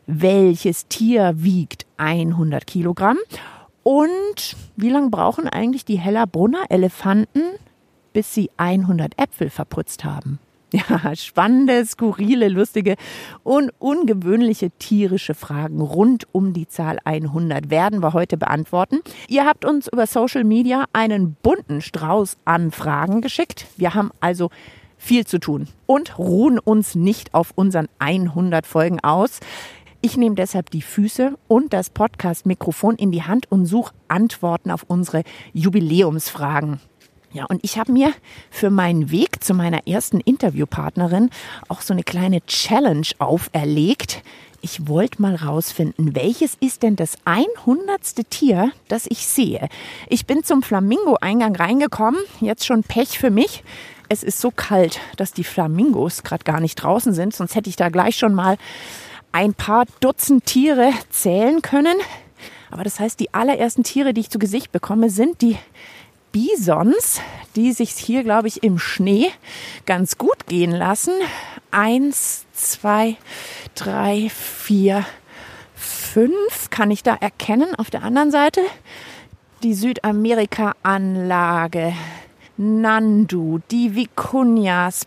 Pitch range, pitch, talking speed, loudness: 175-235 Hz, 205 Hz, 135 wpm, -19 LUFS